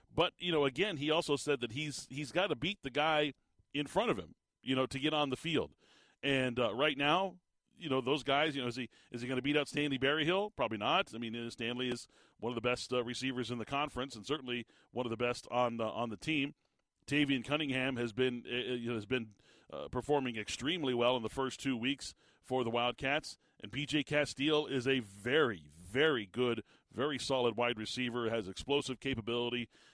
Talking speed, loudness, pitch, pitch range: 220 wpm, -35 LUFS, 130 Hz, 120-145 Hz